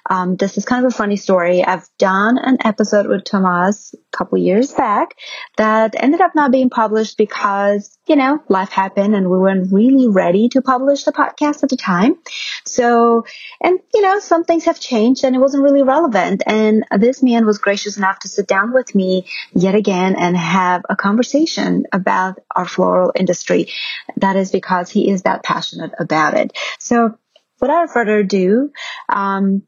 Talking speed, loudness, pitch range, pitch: 180 wpm, -15 LUFS, 195-265 Hz, 215 Hz